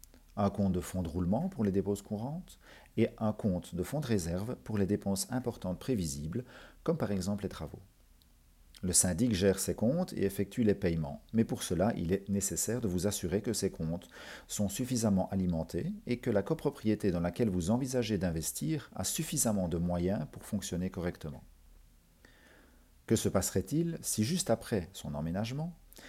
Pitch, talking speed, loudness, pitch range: 100 Hz, 175 wpm, -33 LUFS, 90-115 Hz